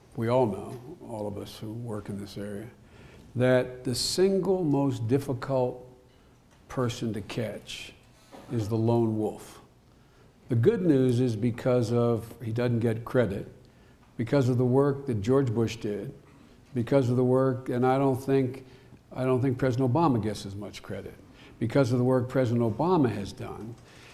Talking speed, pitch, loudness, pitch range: 165 wpm, 125 Hz, -27 LUFS, 115-130 Hz